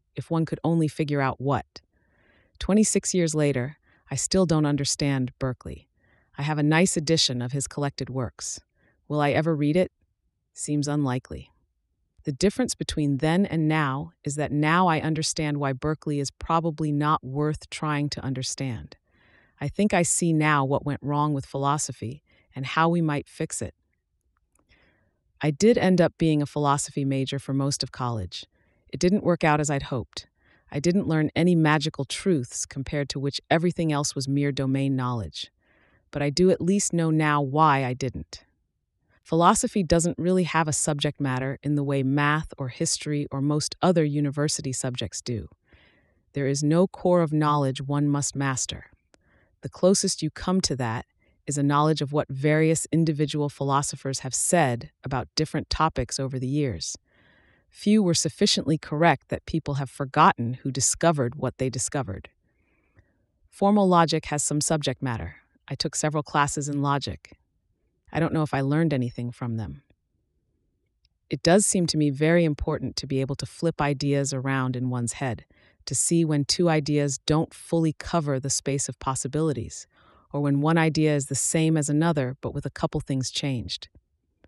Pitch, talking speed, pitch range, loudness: 145 Hz, 170 wpm, 130-160 Hz, -25 LUFS